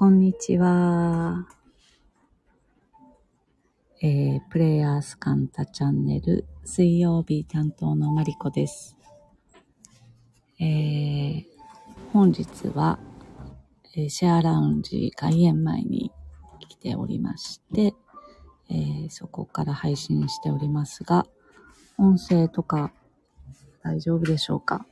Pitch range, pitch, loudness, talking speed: 125-175 Hz, 150 Hz, -24 LUFS, 185 characters per minute